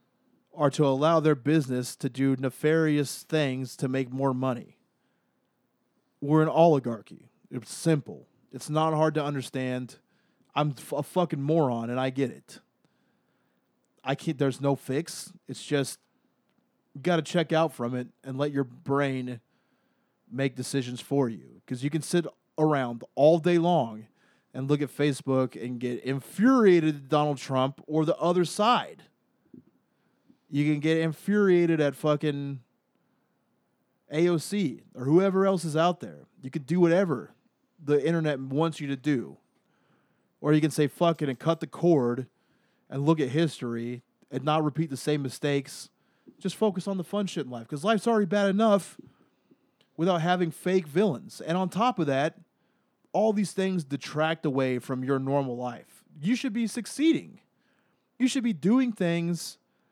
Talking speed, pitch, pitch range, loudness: 160 wpm, 150 Hz, 135-175 Hz, -27 LUFS